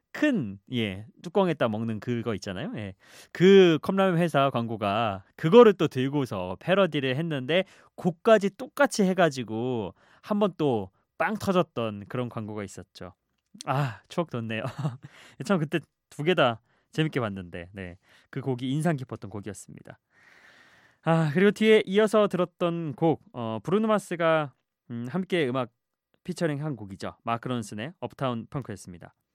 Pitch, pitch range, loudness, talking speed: 135 Hz, 110-175 Hz, -26 LUFS, 290 characters per minute